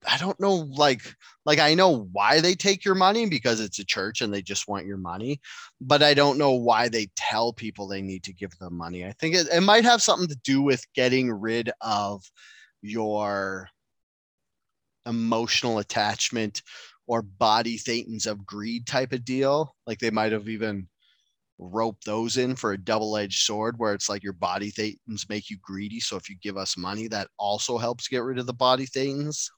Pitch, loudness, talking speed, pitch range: 115 Hz, -25 LUFS, 195 wpm, 100-135 Hz